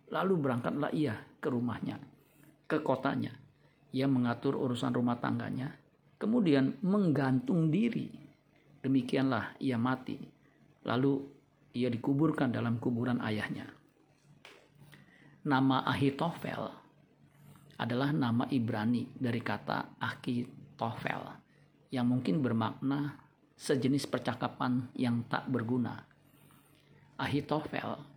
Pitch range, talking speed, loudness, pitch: 120-145 Hz, 85 wpm, -33 LUFS, 135 Hz